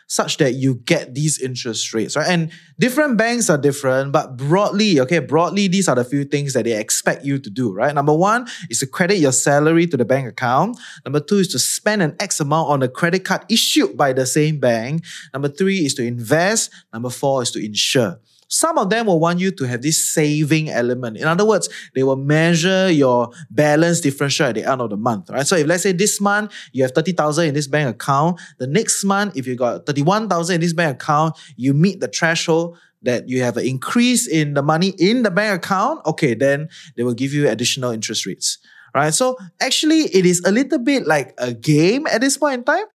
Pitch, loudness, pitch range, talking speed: 155 Hz, -18 LUFS, 135-190 Hz, 220 wpm